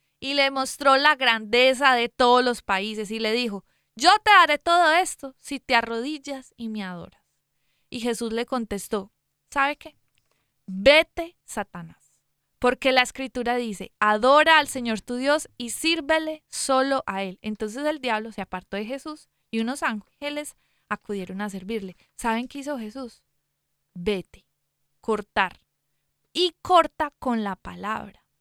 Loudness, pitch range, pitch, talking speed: -23 LUFS, 210-285 Hz, 245 Hz, 145 wpm